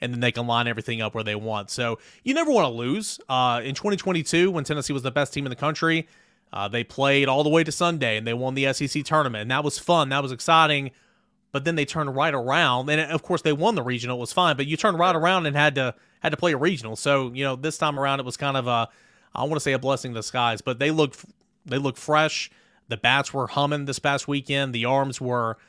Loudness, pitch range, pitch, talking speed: -23 LUFS, 125-160 Hz, 140 Hz, 265 wpm